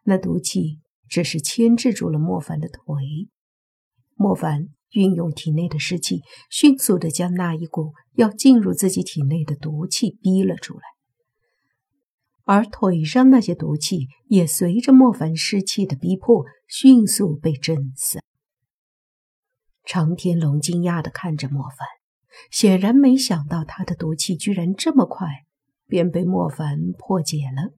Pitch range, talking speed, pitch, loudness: 150-200 Hz, 205 characters per minute, 175 Hz, -19 LUFS